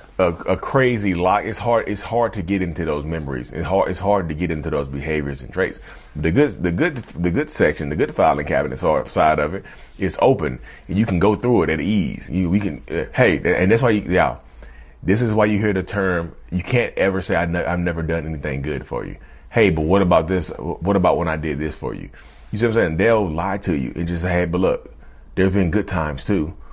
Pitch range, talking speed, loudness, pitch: 75-100 Hz, 250 wpm, -20 LUFS, 90 Hz